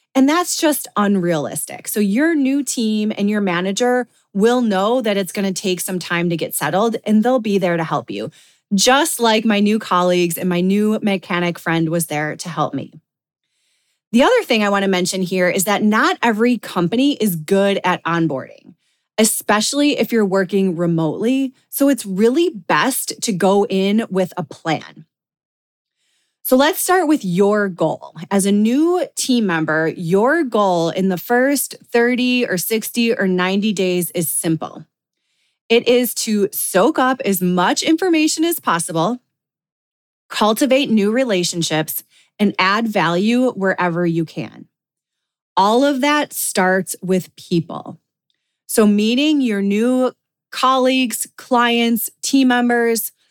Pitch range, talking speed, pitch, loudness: 180-245 Hz, 150 wpm, 205 Hz, -17 LUFS